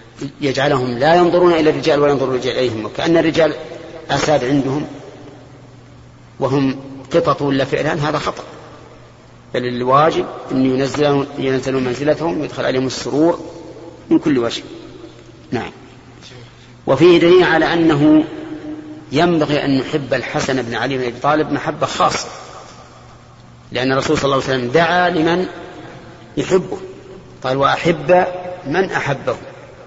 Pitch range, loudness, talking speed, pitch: 130-165 Hz, -16 LUFS, 120 wpm, 145 Hz